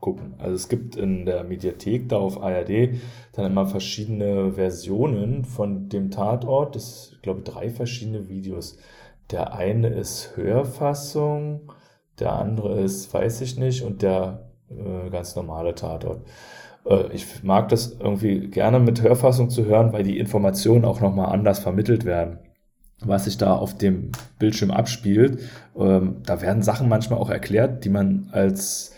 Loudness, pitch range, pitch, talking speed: -23 LUFS, 95-120 Hz, 105 Hz, 155 wpm